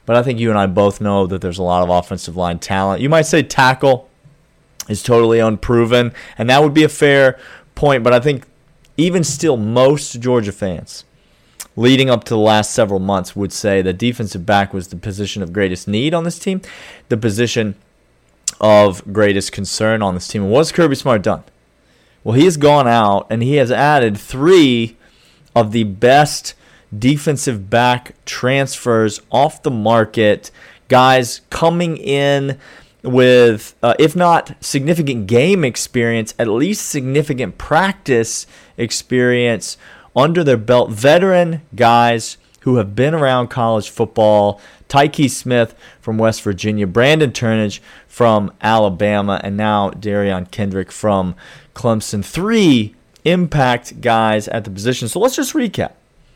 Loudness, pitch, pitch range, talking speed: -15 LUFS, 120 Hz, 105-140 Hz, 150 wpm